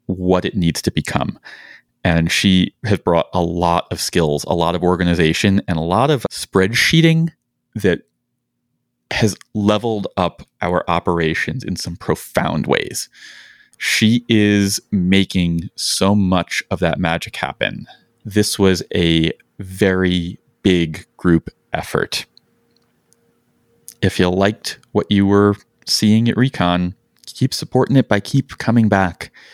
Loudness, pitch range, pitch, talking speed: -17 LUFS, 85-110 Hz, 95 Hz, 130 wpm